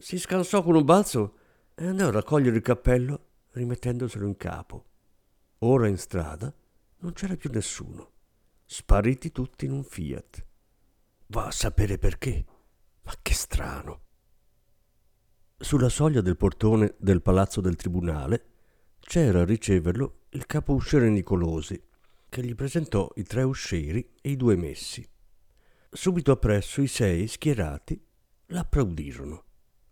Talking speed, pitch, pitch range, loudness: 130 wpm, 110 Hz, 95-135 Hz, -26 LUFS